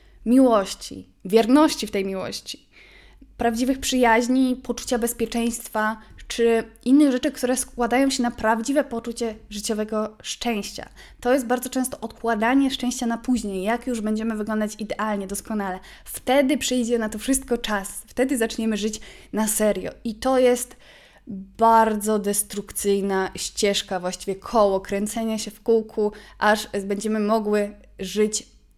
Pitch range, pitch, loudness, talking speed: 210-245 Hz, 225 Hz, -23 LUFS, 125 wpm